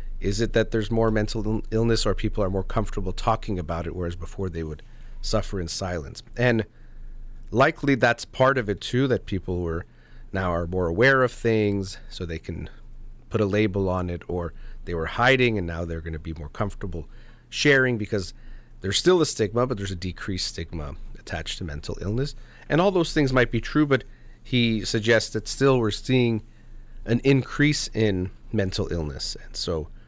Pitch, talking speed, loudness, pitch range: 110 Hz, 190 wpm, -25 LUFS, 90-120 Hz